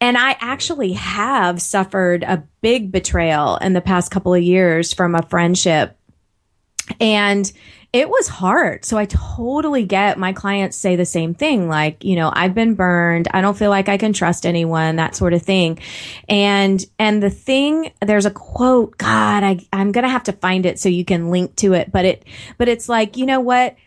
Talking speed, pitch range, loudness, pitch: 200 wpm, 175-215 Hz, -17 LUFS, 195 Hz